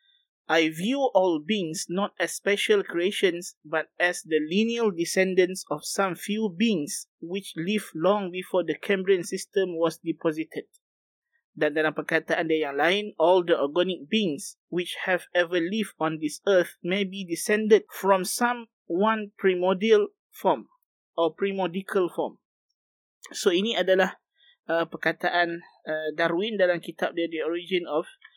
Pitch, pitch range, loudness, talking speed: 185 Hz, 165-205 Hz, -26 LUFS, 140 wpm